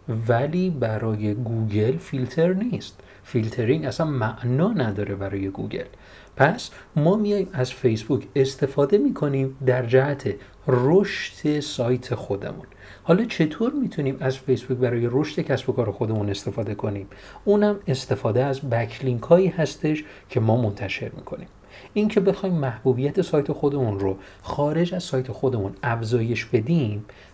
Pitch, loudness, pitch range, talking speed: 130 Hz, -23 LUFS, 115-155 Hz, 125 wpm